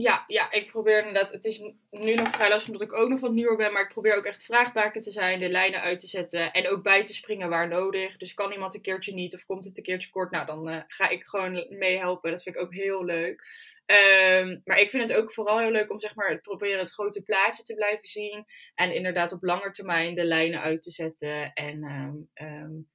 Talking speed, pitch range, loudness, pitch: 250 wpm, 175-210 Hz, -25 LUFS, 195 Hz